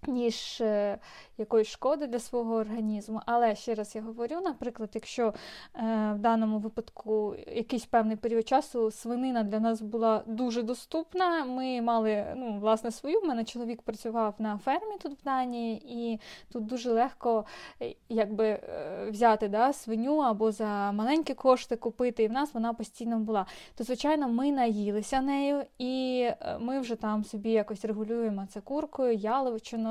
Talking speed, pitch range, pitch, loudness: 150 wpm, 220-255 Hz, 230 Hz, -30 LUFS